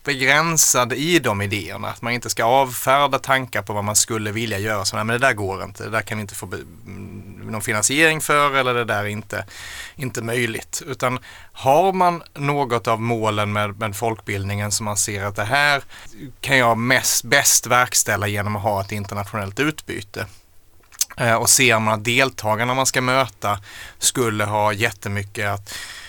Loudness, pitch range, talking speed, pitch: -19 LUFS, 105-130 Hz, 175 wpm, 110 Hz